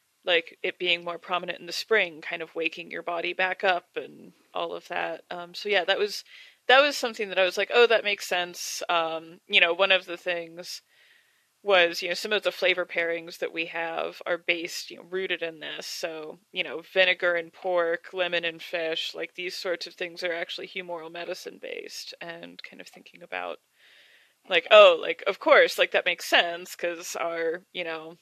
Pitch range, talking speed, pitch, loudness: 170-200 Hz, 205 wpm, 180 Hz, -25 LUFS